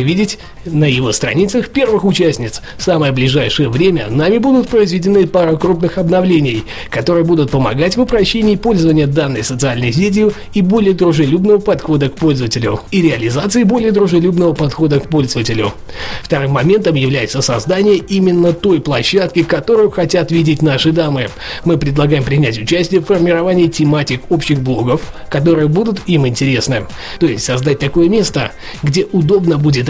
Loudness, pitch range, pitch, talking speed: -13 LUFS, 140-185 Hz, 165 Hz, 145 wpm